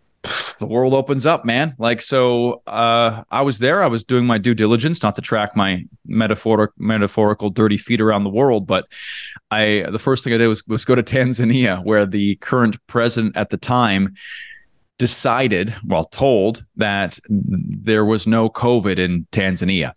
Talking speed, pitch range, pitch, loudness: 170 wpm, 105-120 Hz, 110 Hz, -18 LUFS